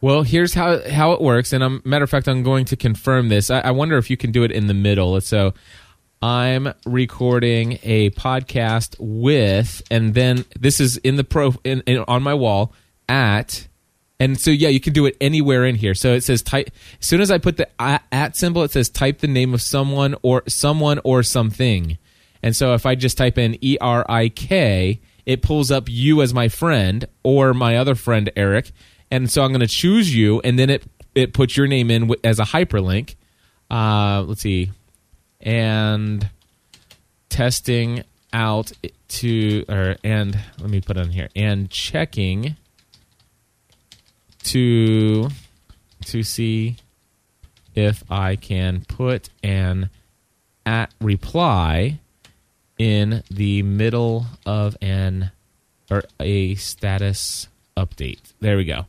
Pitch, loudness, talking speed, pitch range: 115 Hz, -19 LUFS, 160 wpm, 100-130 Hz